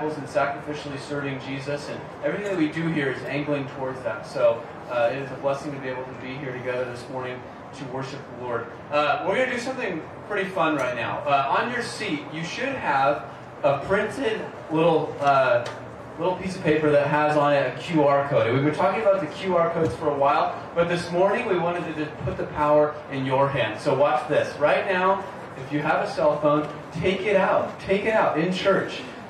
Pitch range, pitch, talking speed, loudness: 140-170 Hz, 150 Hz, 220 wpm, -24 LUFS